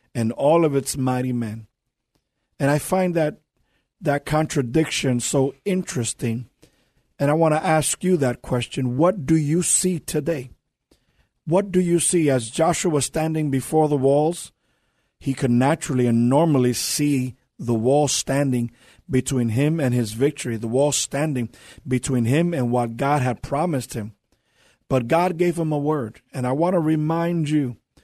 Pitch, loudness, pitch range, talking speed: 140 Hz, -21 LUFS, 125-160 Hz, 160 wpm